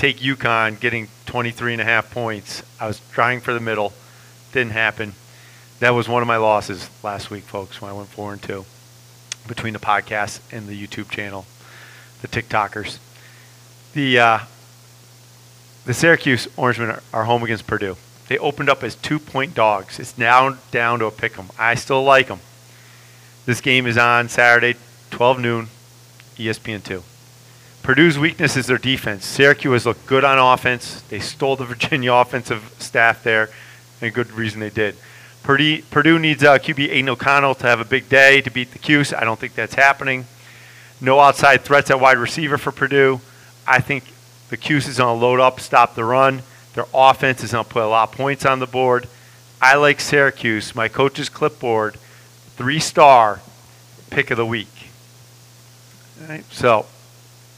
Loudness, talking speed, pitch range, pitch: -17 LUFS, 170 wpm, 100-130 Hz, 120 Hz